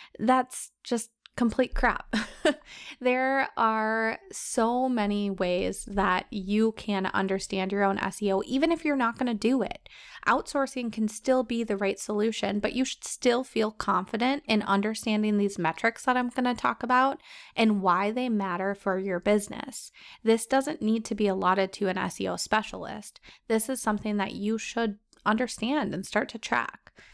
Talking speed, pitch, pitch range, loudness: 165 wpm, 225 Hz, 205-255 Hz, -28 LUFS